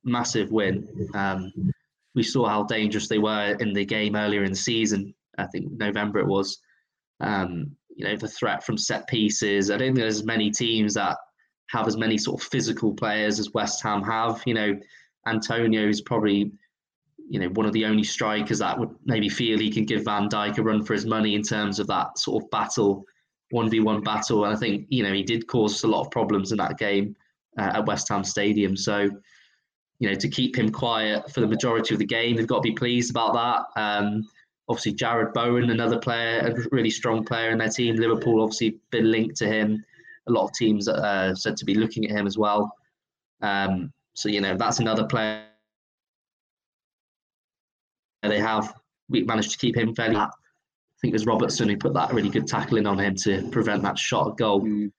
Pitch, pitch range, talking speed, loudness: 110 Hz, 105-115 Hz, 210 wpm, -24 LUFS